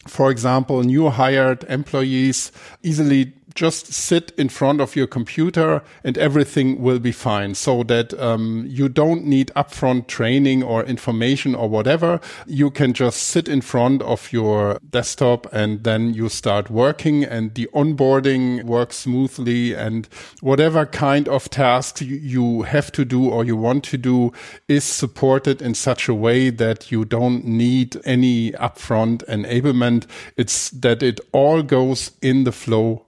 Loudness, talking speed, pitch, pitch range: -19 LUFS, 155 wpm, 130 Hz, 115-140 Hz